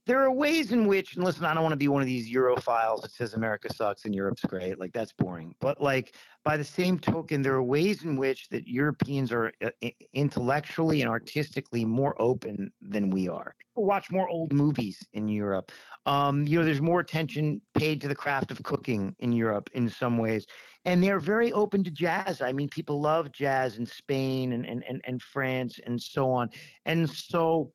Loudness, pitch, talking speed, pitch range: -29 LUFS, 140 Hz, 210 wpm, 120-160 Hz